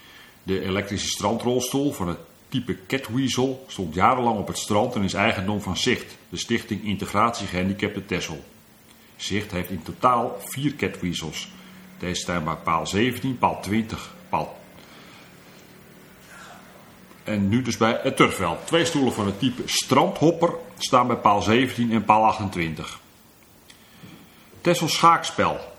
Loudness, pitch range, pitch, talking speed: -23 LUFS, 95-125 Hz, 105 Hz, 135 wpm